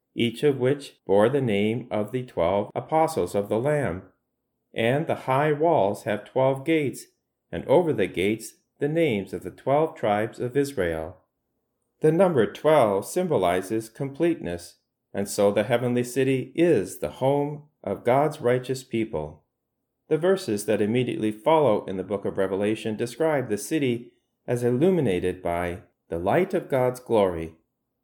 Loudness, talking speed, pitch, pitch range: -24 LUFS, 150 wpm, 125 Hz, 100-145 Hz